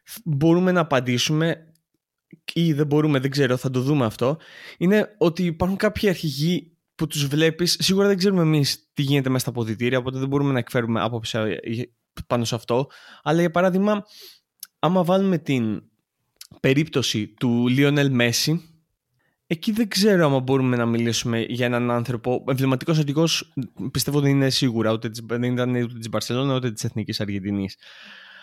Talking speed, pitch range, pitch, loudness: 150 wpm, 120-165 Hz, 135 Hz, -22 LUFS